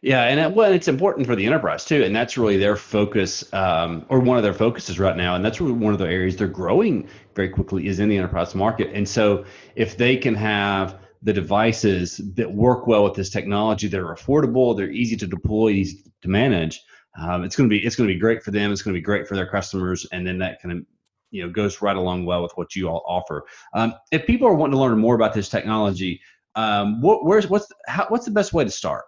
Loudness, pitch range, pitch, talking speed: -21 LUFS, 95-115 Hz, 105 Hz, 250 wpm